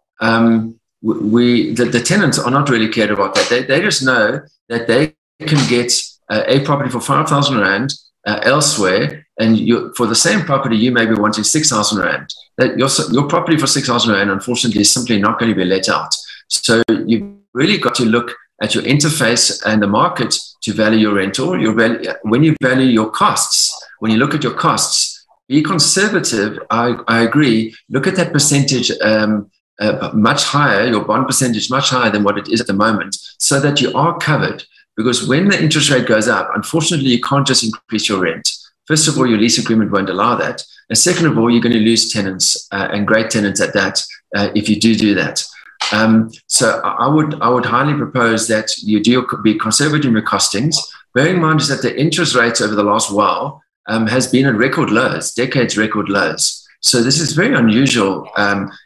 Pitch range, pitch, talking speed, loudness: 110-140 Hz, 115 Hz, 210 wpm, -14 LUFS